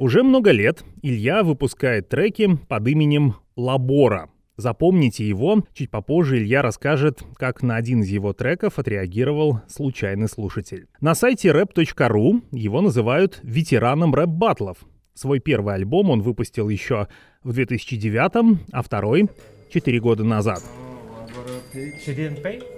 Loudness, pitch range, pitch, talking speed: -20 LUFS, 110-155 Hz, 130 Hz, 120 wpm